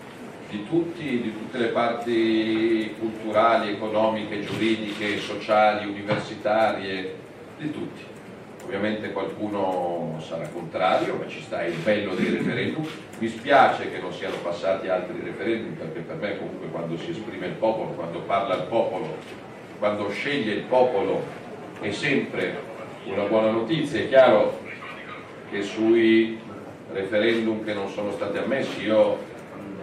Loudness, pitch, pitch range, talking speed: -25 LUFS, 110 Hz, 100-115 Hz, 130 wpm